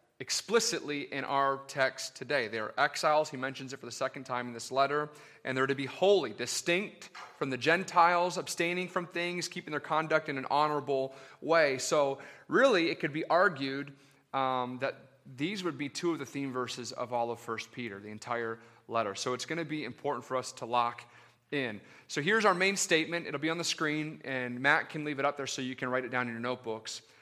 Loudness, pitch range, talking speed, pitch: -31 LUFS, 125-160 Hz, 215 wpm, 135 Hz